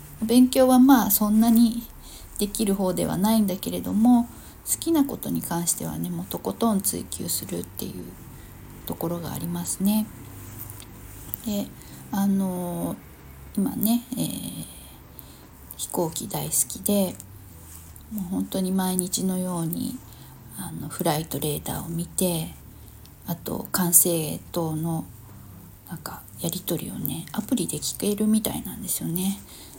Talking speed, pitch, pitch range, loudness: 255 characters per minute, 185 Hz, 150-215 Hz, -24 LUFS